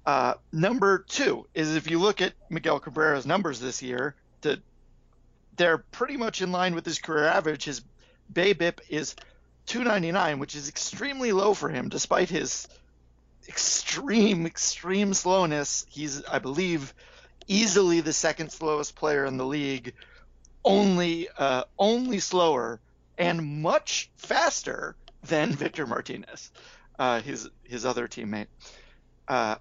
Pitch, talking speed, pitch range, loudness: 165 Hz, 135 wpm, 140-195 Hz, -27 LUFS